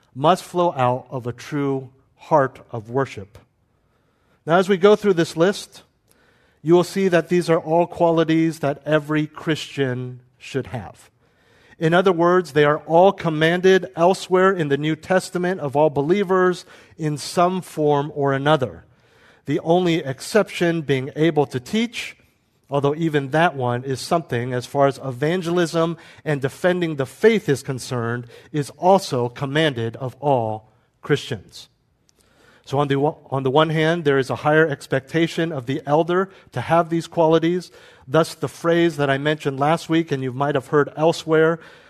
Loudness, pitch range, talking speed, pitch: -20 LUFS, 135-170 Hz, 160 wpm, 150 Hz